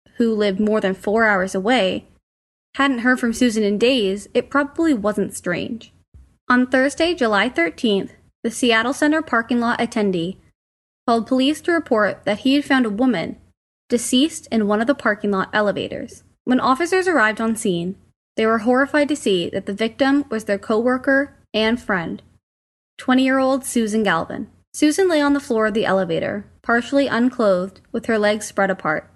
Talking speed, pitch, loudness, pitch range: 170 wpm, 230 Hz, -19 LUFS, 205-265 Hz